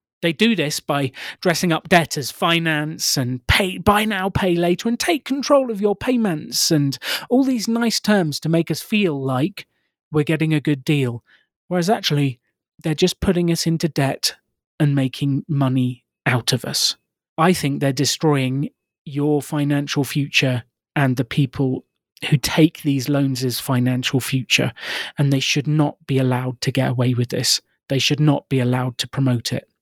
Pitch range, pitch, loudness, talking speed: 135-170 Hz, 150 Hz, -20 LUFS, 175 wpm